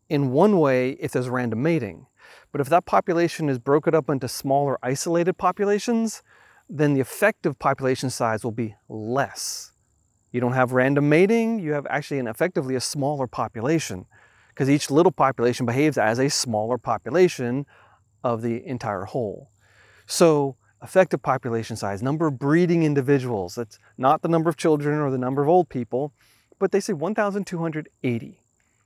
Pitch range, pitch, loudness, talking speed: 120-165 Hz, 140 Hz, -23 LUFS, 160 wpm